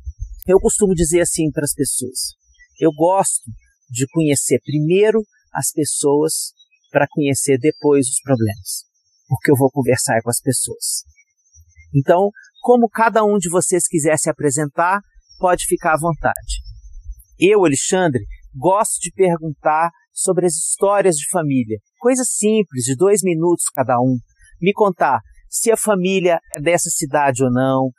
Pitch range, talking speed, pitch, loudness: 130-185 Hz, 140 wpm, 155 Hz, -17 LUFS